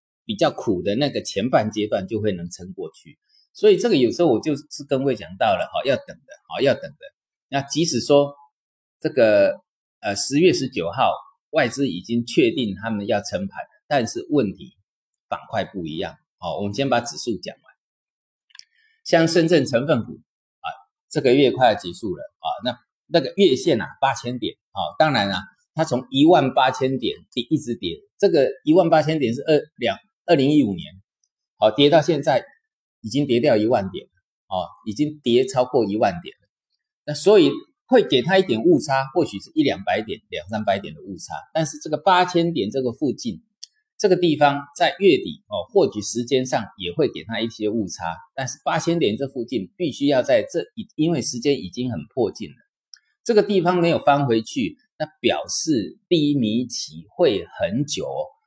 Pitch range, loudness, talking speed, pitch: 120-185 Hz, -21 LUFS, 260 characters per minute, 145 Hz